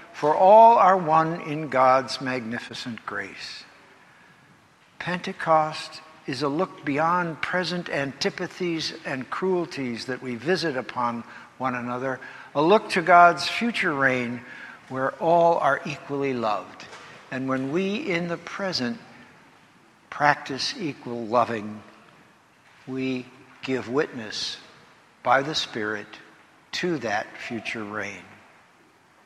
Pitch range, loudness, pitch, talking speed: 130-175 Hz, -24 LUFS, 145 Hz, 110 wpm